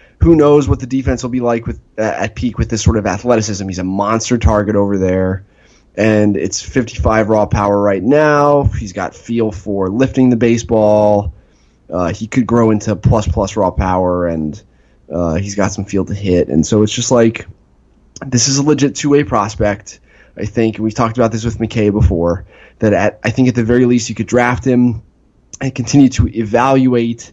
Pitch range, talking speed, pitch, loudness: 100-120 Hz, 195 wpm, 110 Hz, -14 LUFS